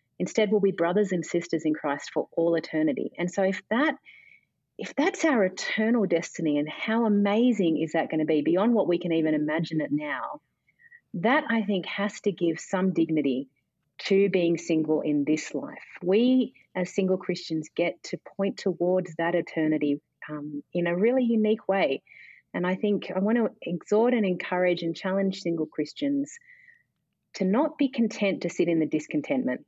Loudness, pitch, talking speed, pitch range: -26 LUFS, 185 Hz, 180 wpm, 165-220 Hz